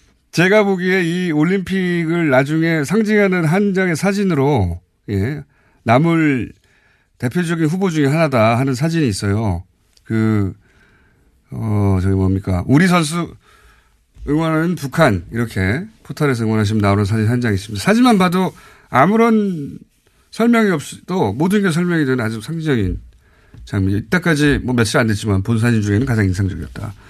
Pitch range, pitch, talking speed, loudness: 105-175 Hz, 140 Hz, 315 characters per minute, -16 LUFS